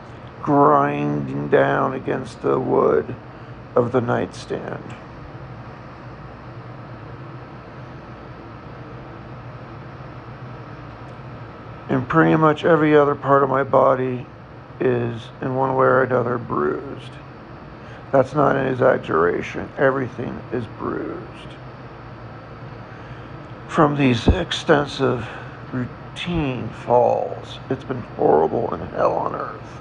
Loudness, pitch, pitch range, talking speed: -20 LUFS, 125 Hz, 120-140 Hz, 85 wpm